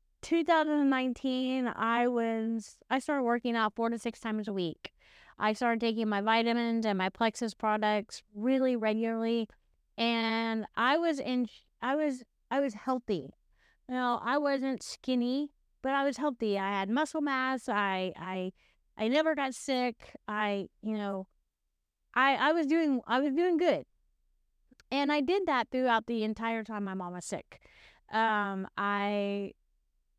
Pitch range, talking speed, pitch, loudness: 215-265 Hz, 155 wpm, 235 Hz, -31 LUFS